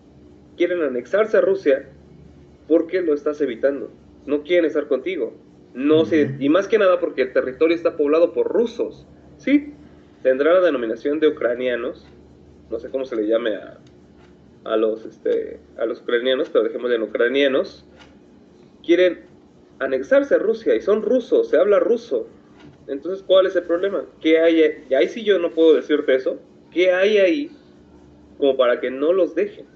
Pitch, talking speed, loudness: 175 Hz, 165 wpm, -20 LUFS